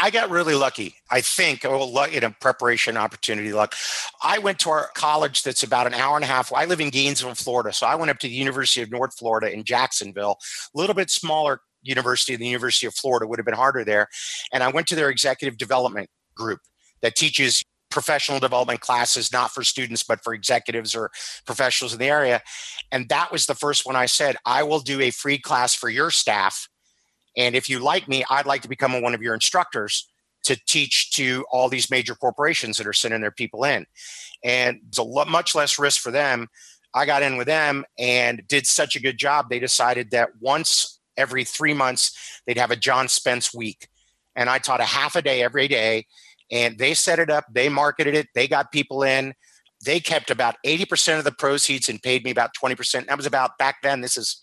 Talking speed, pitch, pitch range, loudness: 220 wpm, 130 Hz, 120-145 Hz, -21 LUFS